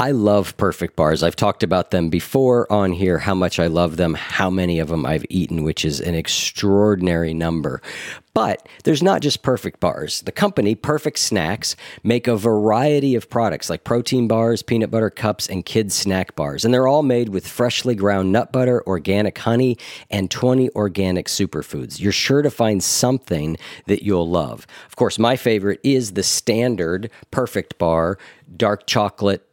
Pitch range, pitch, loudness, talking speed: 90-120 Hz, 100 Hz, -19 LUFS, 175 wpm